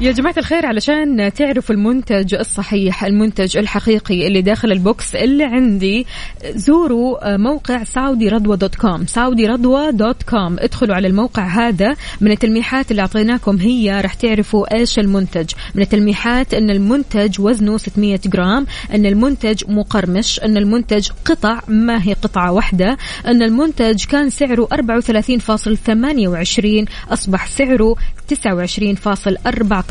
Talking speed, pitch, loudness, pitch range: 120 wpm, 220 Hz, -15 LUFS, 205-245 Hz